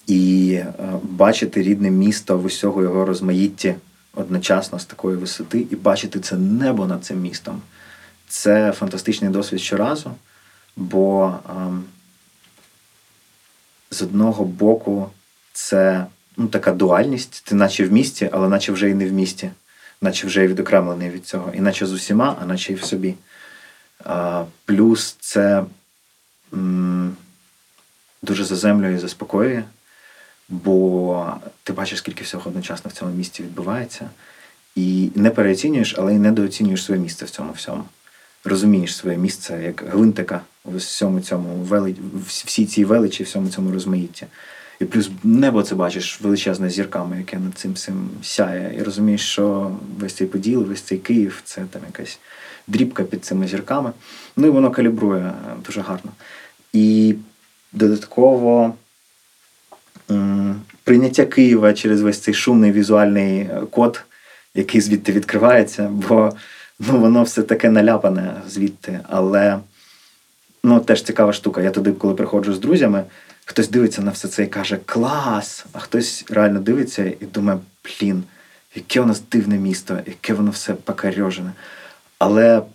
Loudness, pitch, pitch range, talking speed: -18 LUFS, 100 Hz, 95-110 Hz, 140 wpm